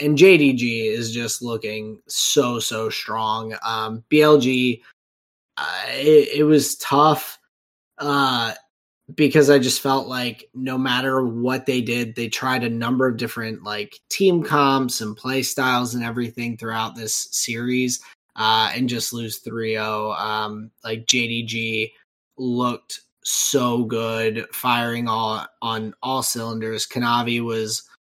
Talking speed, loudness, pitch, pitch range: 130 wpm, -21 LUFS, 120 Hz, 110-130 Hz